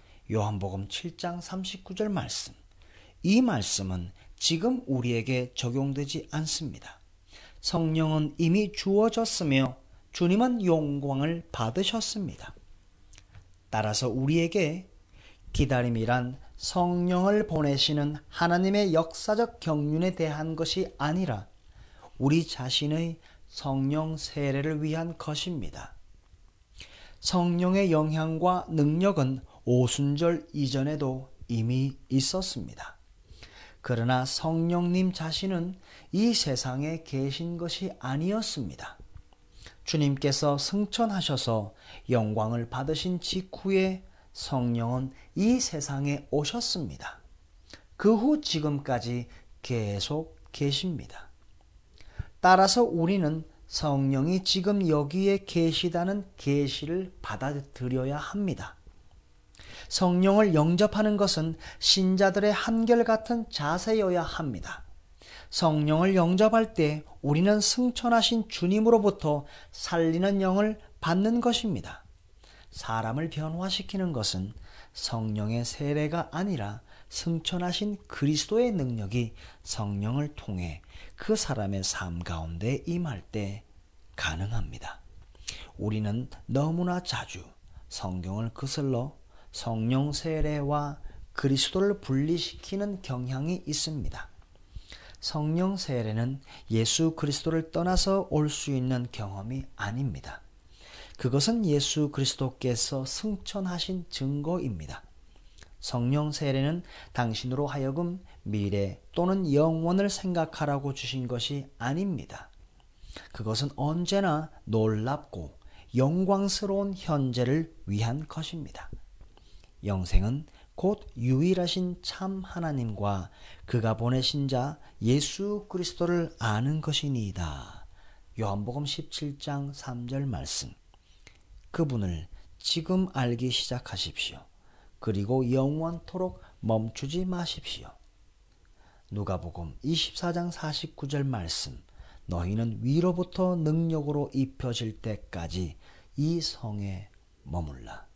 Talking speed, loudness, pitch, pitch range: 225 characters per minute, -29 LUFS, 145 Hz, 110-175 Hz